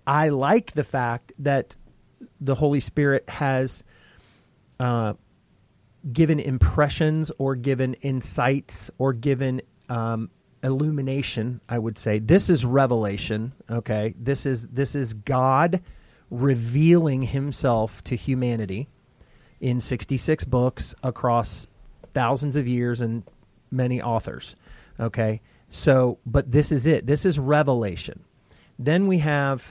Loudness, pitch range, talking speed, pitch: -24 LUFS, 115-140 Hz, 115 wpm, 130 Hz